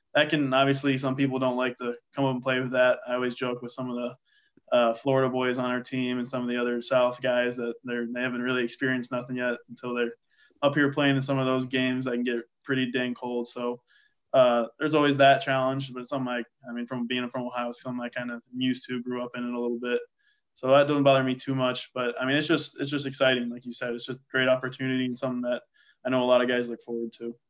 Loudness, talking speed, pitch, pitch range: -27 LUFS, 270 wpm, 125 Hz, 120-135 Hz